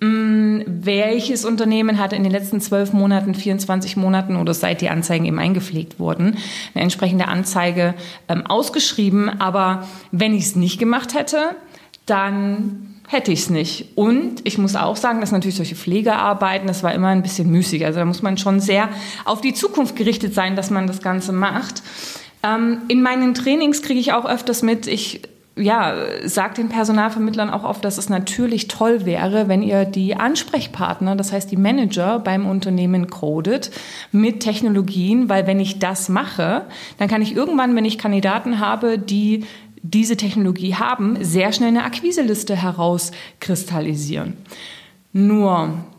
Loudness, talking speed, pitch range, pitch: -19 LUFS, 160 wpm, 190-225 Hz, 200 Hz